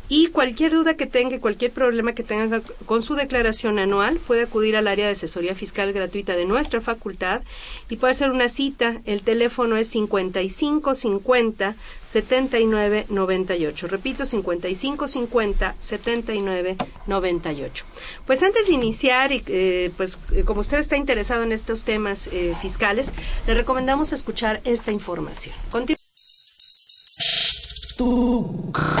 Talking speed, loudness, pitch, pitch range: 120 wpm, -22 LUFS, 225 Hz, 200-255 Hz